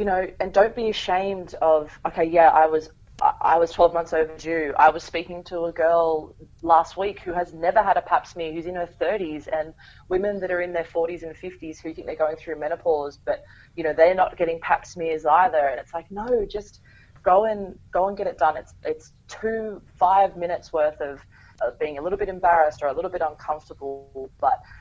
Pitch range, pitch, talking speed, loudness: 155-185 Hz, 165 Hz, 220 wpm, -23 LUFS